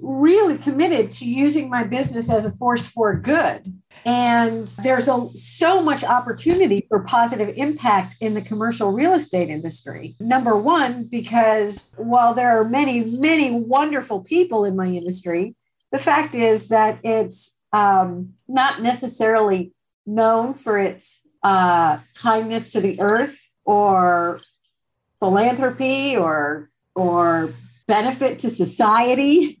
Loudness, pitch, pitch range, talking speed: -19 LUFS, 225 Hz, 200-260 Hz, 125 wpm